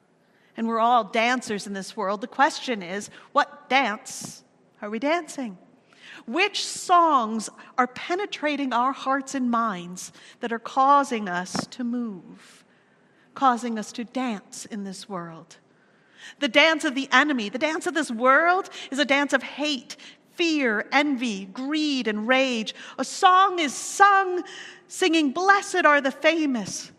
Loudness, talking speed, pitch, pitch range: -23 LUFS, 145 wpm, 265 Hz, 230-305 Hz